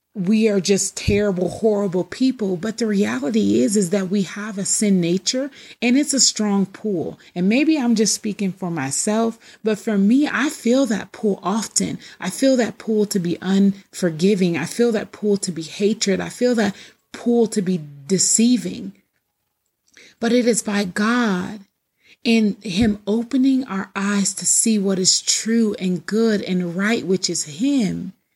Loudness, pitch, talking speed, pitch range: -19 LUFS, 210 Hz, 170 wpm, 190-230 Hz